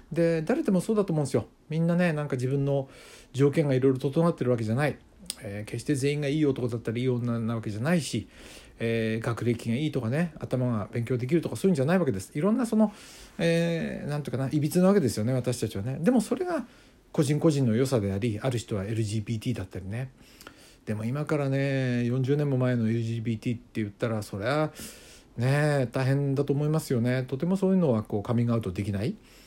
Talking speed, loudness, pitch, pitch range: 430 characters per minute, -27 LUFS, 130 Hz, 115-155 Hz